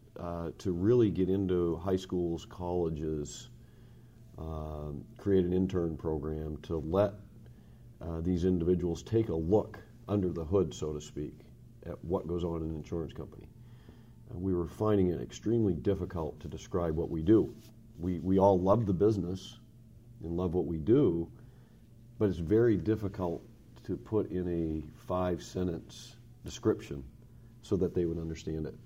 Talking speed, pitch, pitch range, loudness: 155 wpm, 90 Hz, 85-115 Hz, -32 LUFS